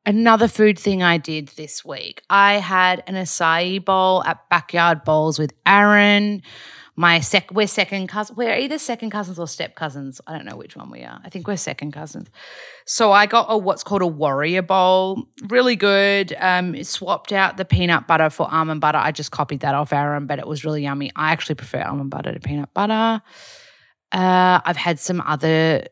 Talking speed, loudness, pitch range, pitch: 200 wpm, -18 LUFS, 155-205 Hz, 180 Hz